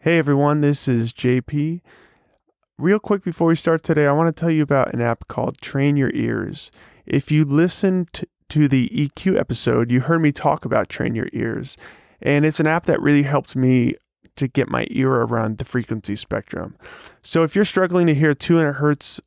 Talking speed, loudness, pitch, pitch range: 195 wpm, -19 LUFS, 145 Hz, 130-165 Hz